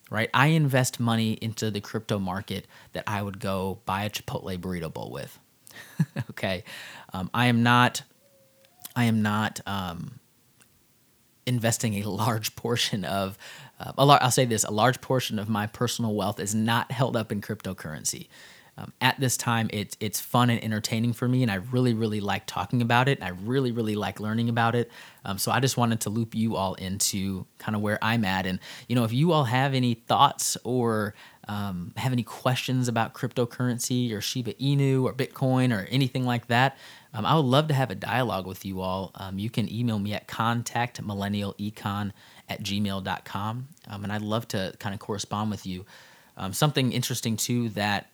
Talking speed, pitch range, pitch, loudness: 190 wpm, 100-125 Hz, 115 Hz, -27 LUFS